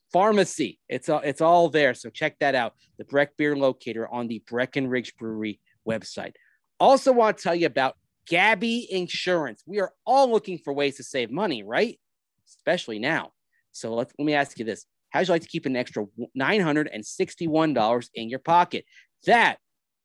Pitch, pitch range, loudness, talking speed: 145 Hz, 120-175 Hz, -24 LUFS, 185 wpm